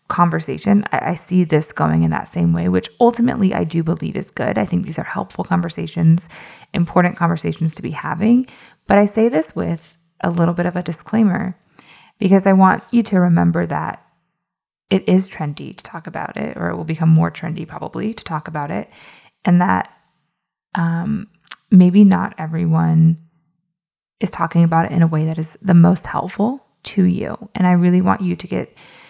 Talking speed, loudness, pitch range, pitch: 190 wpm, -17 LUFS, 160-195 Hz, 170 Hz